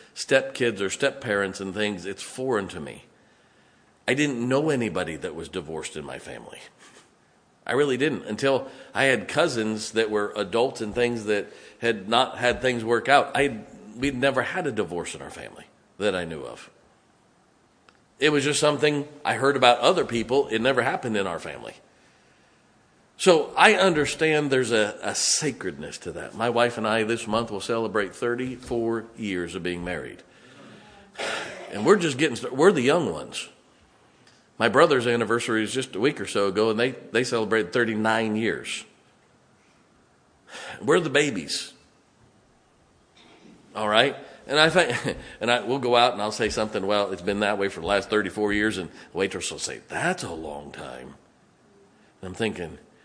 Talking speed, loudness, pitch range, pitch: 170 wpm, -24 LUFS, 105-130 Hz, 115 Hz